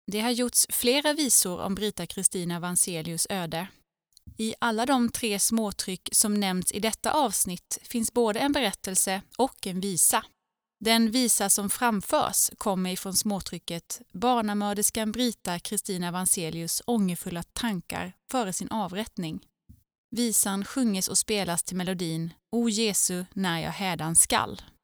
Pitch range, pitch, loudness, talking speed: 185-230 Hz, 200 Hz, -26 LUFS, 135 wpm